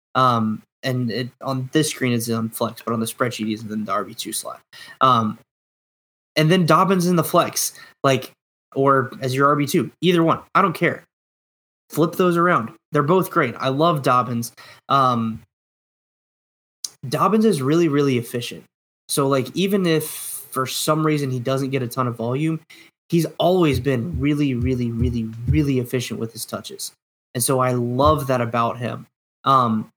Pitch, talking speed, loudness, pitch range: 130 Hz, 165 wpm, -20 LUFS, 120-155 Hz